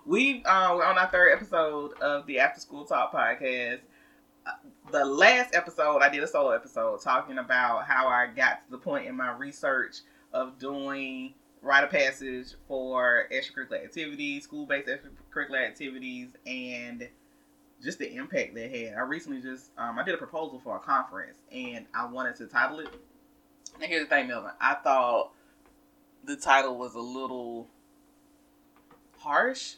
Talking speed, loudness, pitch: 160 wpm, -27 LUFS, 165 Hz